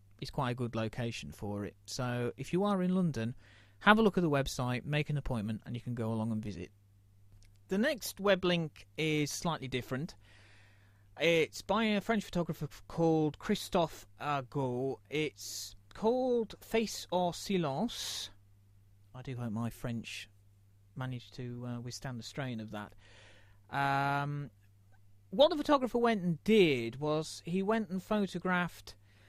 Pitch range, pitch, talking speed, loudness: 100-170 Hz, 125 Hz, 150 wpm, -34 LUFS